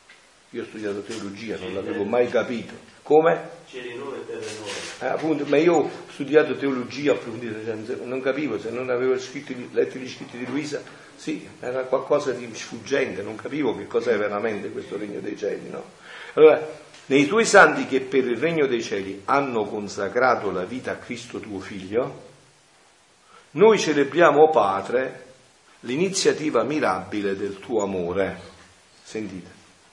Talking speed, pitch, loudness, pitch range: 145 wpm, 130 Hz, -23 LUFS, 105-165 Hz